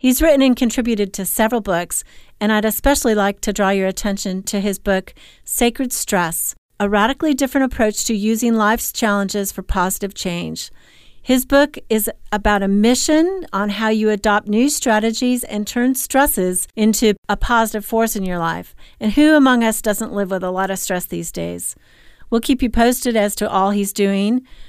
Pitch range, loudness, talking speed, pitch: 200-245 Hz, -17 LUFS, 180 wpm, 215 Hz